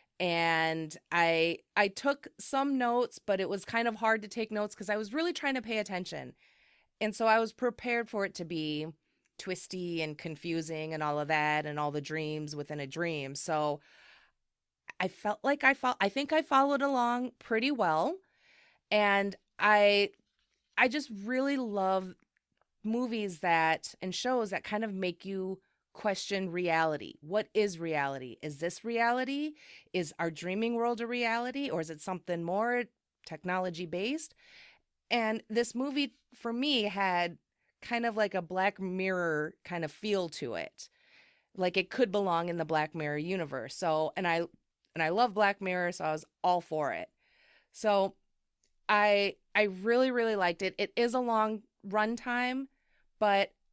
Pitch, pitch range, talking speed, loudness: 200 Hz, 170-235 Hz, 165 wpm, -32 LUFS